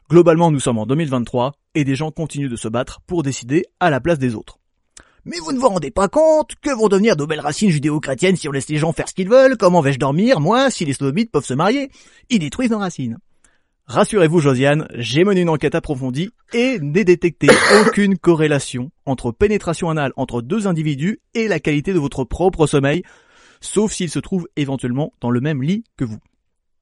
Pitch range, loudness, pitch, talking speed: 135-195 Hz, -17 LUFS, 160 Hz, 205 wpm